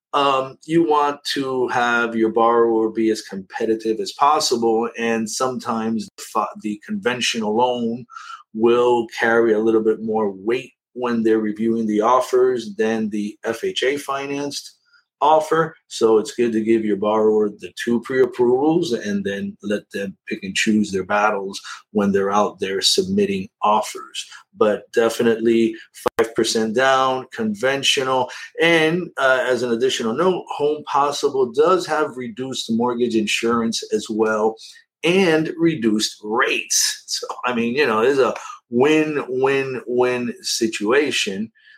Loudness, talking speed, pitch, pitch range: -19 LUFS, 135 wpm, 125 Hz, 110-160 Hz